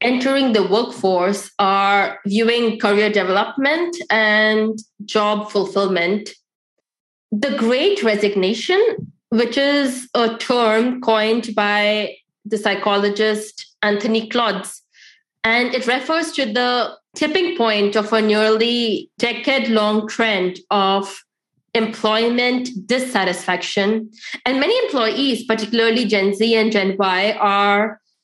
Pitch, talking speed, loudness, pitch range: 220 Hz, 105 wpm, -18 LUFS, 205-240 Hz